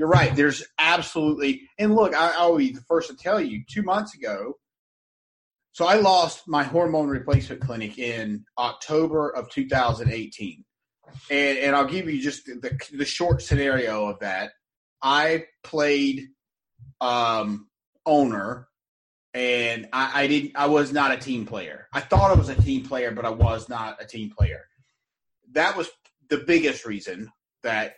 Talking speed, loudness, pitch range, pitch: 160 wpm, -23 LUFS, 115-150 Hz, 135 Hz